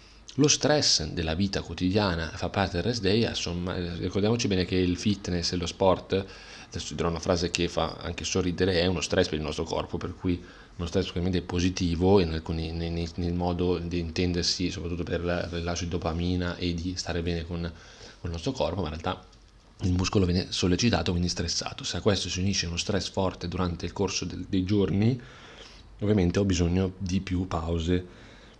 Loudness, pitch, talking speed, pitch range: -28 LUFS, 90 Hz, 185 wpm, 85-95 Hz